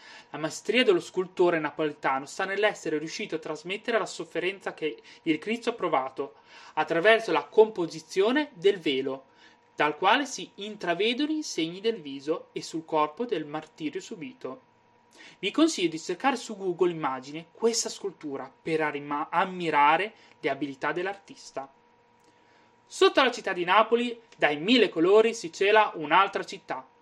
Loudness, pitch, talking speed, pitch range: -27 LUFS, 195 Hz, 140 wpm, 160-230 Hz